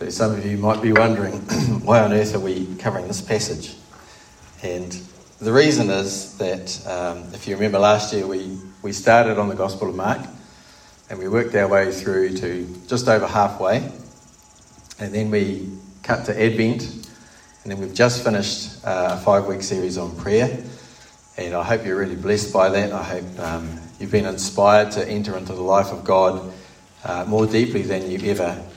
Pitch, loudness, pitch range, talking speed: 100 Hz, -20 LUFS, 95-105 Hz, 180 wpm